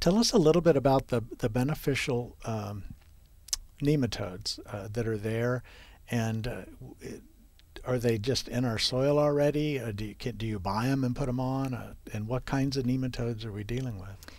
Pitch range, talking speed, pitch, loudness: 105-135 Hz, 195 wpm, 120 Hz, -30 LUFS